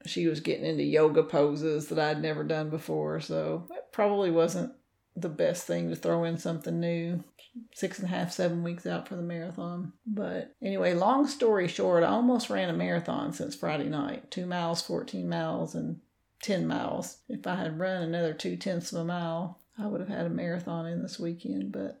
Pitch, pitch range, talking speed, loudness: 170 Hz, 160-185 Hz, 200 wpm, -30 LUFS